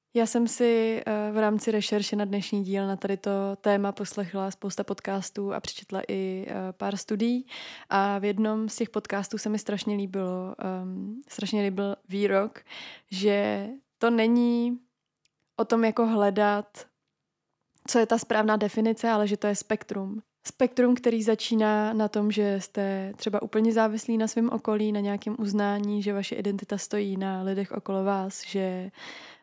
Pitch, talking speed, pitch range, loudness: 210 Hz, 155 wpm, 200-225 Hz, -27 LUFS